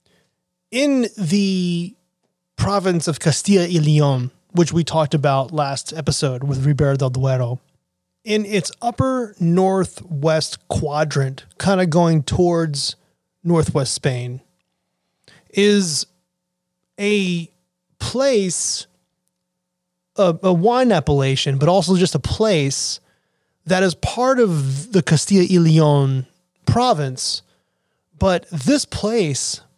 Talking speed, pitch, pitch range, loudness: 105 wpm, 170 Hz, 140-185 Hz, -18 LUFS